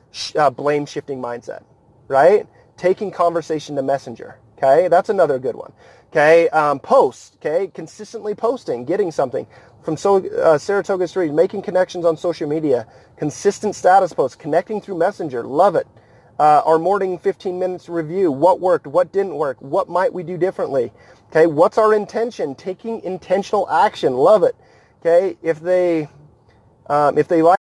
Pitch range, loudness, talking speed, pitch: 150-195 Hz, -18 LUFS, 155 wpm, 180 Hz